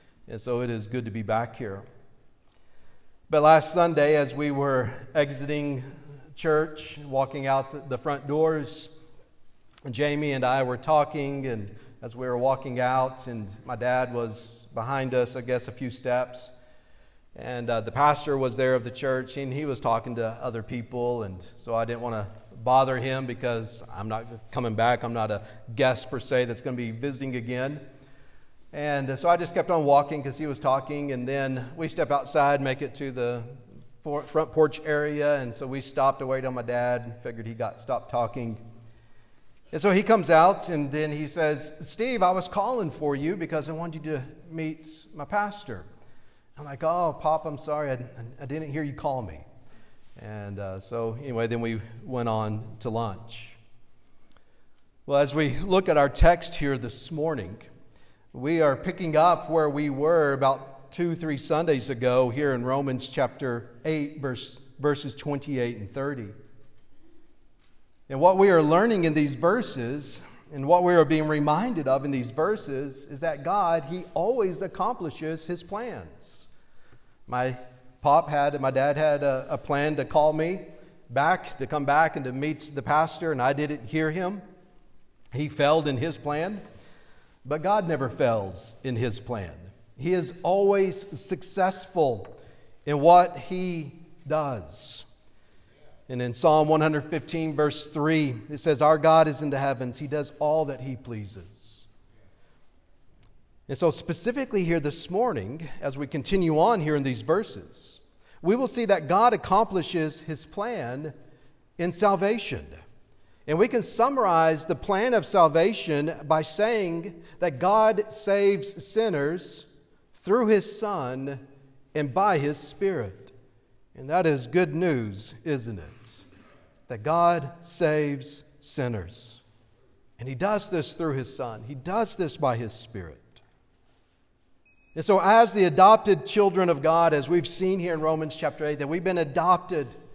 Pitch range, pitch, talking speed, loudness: 125-160 Hz, 140 Hz, 165 wpm, -26 LUFS